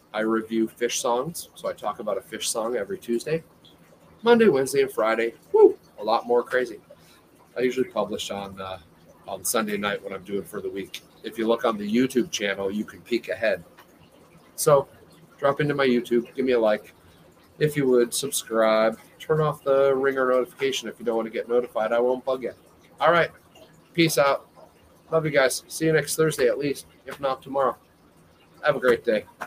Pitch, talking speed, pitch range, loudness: 125 Hz, 195 wpm, 110-140 Hz, -24 LUFS